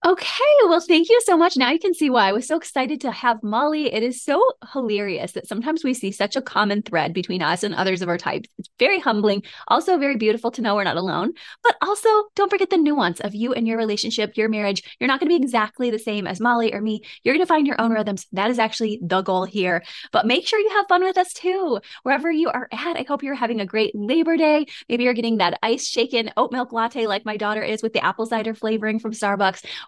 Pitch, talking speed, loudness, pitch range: 235 Hz, 255 wpm, -21 LUFS, 210-310 Hz